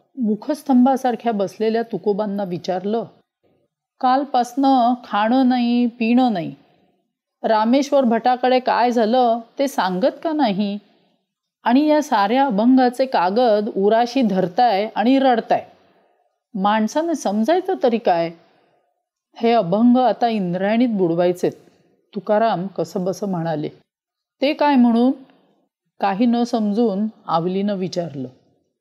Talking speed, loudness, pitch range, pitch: 100 wpm, -19 LUFS, 195-255 Hz, 225 Hz